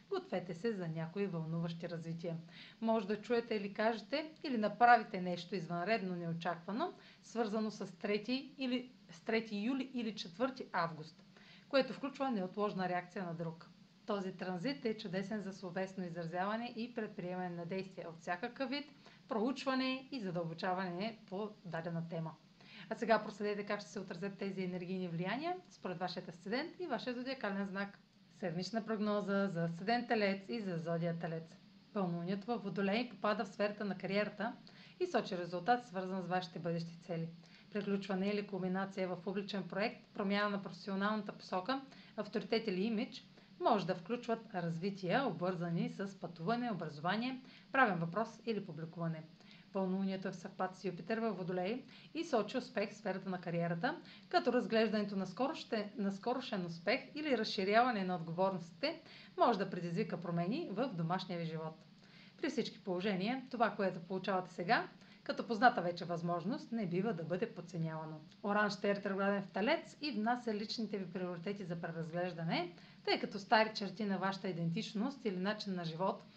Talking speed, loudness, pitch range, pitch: 150 wpm, -39 LUFS, 180-225 Hz, 200 Hz